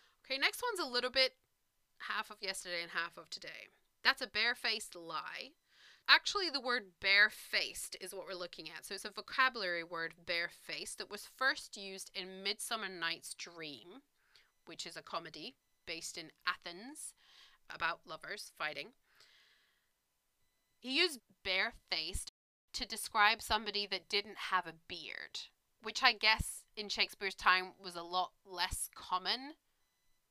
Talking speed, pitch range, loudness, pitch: 145 wpm, 180-240 Hz, -36 LUFS, 200 Hz